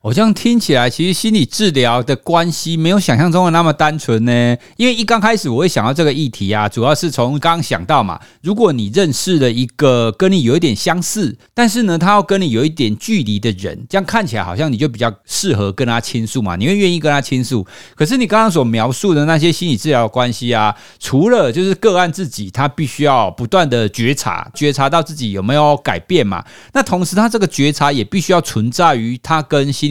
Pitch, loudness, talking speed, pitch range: 150 Hz, -14 LUFS, 340 characters per minute, 120-185 Hz